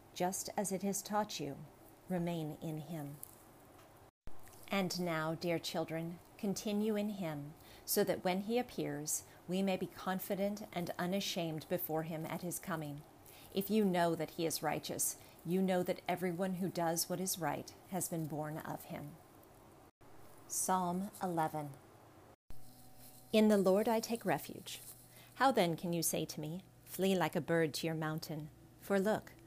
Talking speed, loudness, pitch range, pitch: 155 wpm, -37 LUFS, 155-190 Hz, 170 Hz